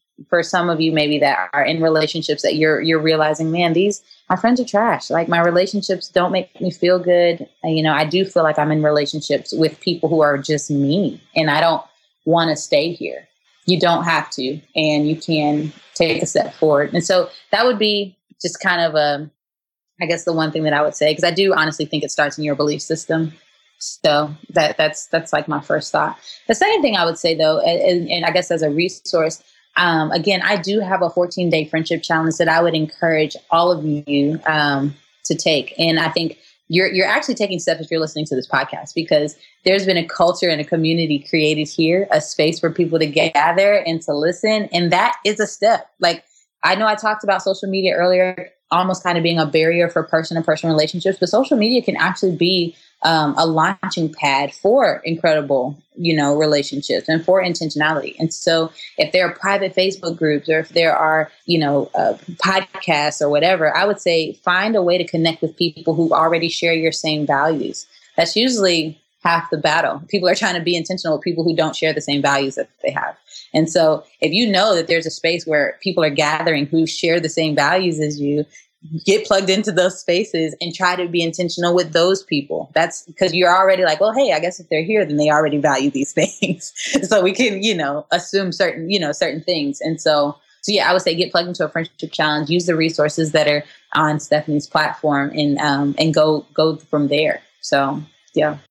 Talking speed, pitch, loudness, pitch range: 215 wpm, 165 Hz, -18 LUFS, 155-180 Hz